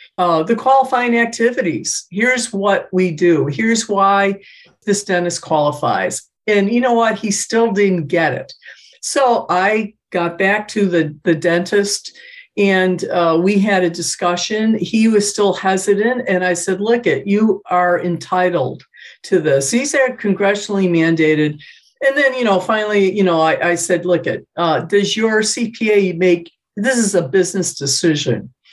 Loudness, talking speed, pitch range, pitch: -16 LUFS, 160 wpm, 175-220 Hz, 195 Hz